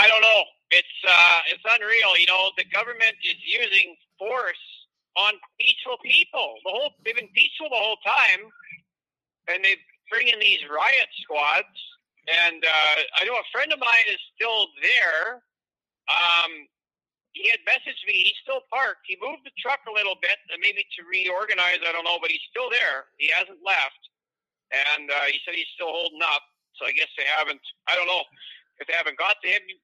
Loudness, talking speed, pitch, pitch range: -21 LUFS, 185 wpm, 200 Hz, 175-280 Hz